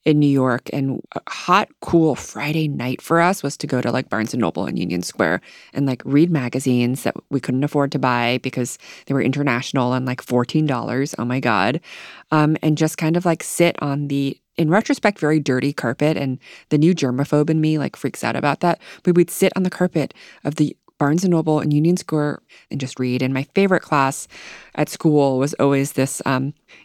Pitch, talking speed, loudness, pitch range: 140 Hz, 210 wpm, -20 LUFS, 130-155 Hz